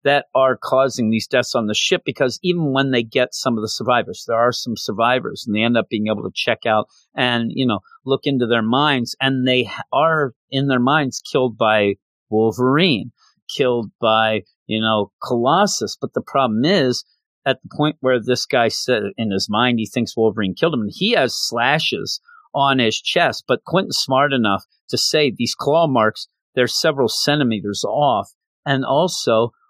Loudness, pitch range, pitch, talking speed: -18 LUFS, 110-135 Hz, 125 Hz, 185 wpm